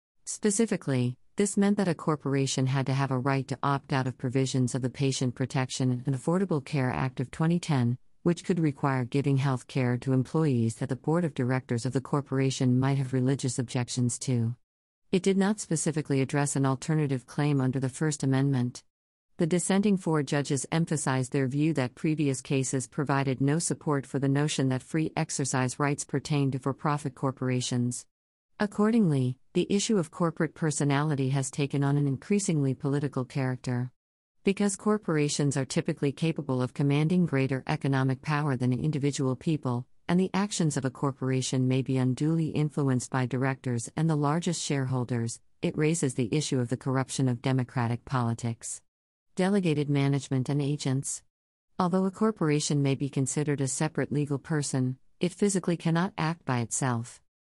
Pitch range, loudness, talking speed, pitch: 130-155 Hz, -28 LUFS, 165 wpm, 140 Hz